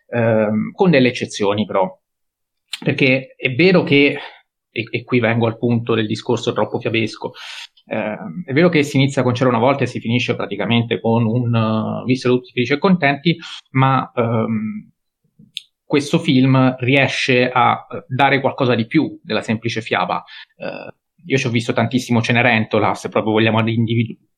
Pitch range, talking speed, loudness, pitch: 115-135 Hz, 160 wpm, -17 LUFS, 125 Hz